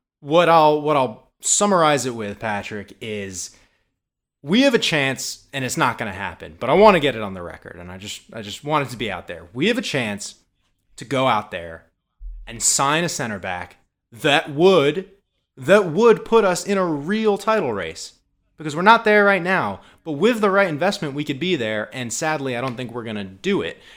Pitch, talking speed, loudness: 150 Hz, 215 wpm, -19 LUFS